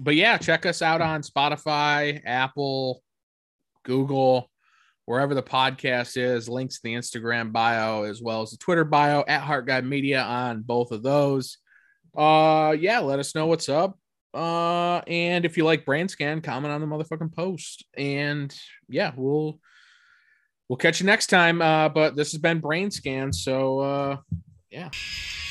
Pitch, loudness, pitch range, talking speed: 145 Hz, -24 LUFS, 130-160 Hz, 160 wpm